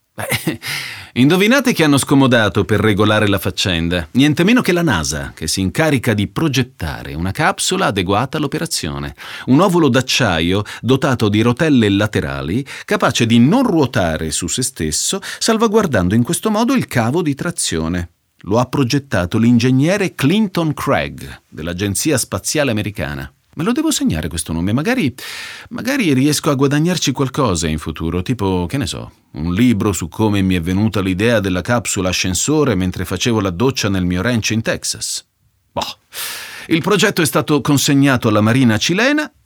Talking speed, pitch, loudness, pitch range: 155 wpm, 120 Hz, -16 LUFS, 95-150 Hz